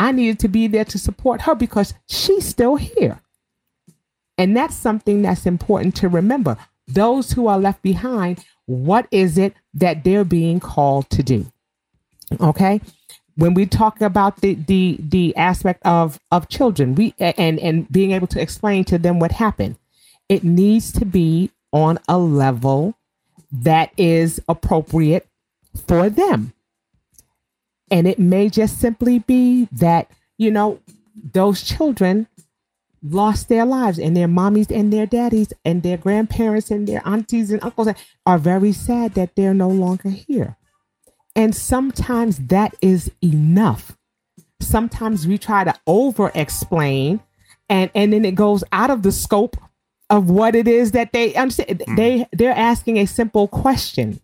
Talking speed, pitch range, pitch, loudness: 155 wpm, 175-220 Hz, 195 Hz, -17 LUFS